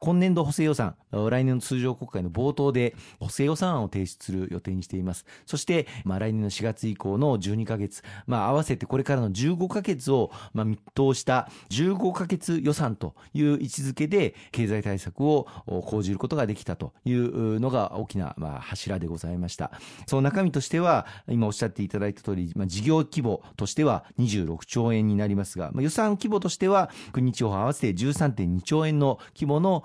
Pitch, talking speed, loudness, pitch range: 120 Hz, 360 characters per minute, -27 LUFS, 100-145 Hz